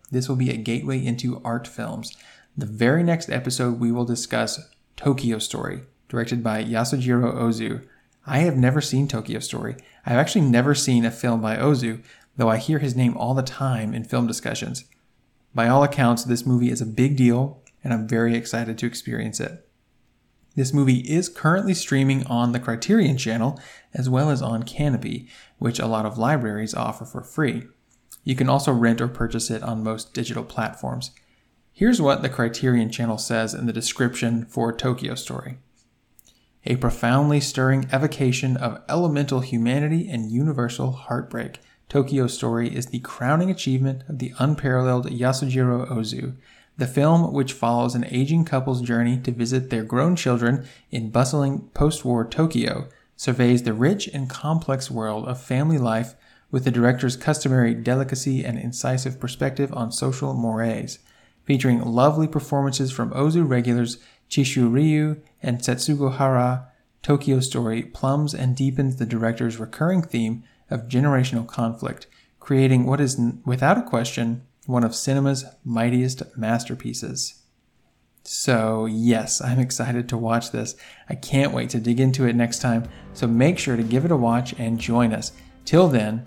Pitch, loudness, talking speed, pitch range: 125 Hz, -22 LUFS, 160 wpm, 115-135 Hz